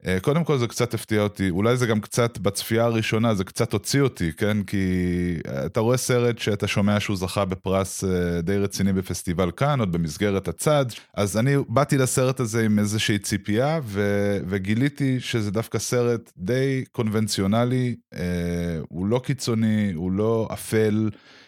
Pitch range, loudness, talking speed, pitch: 95-120 Hz, -23 LUFS, 150 wpm, 105 Hz